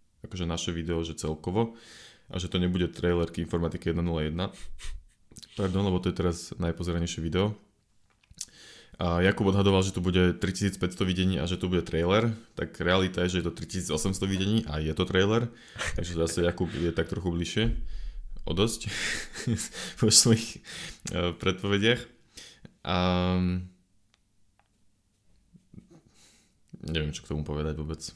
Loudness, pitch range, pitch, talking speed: -28 LUFS, 85-100 Hz, 90 Hz, 135 wpm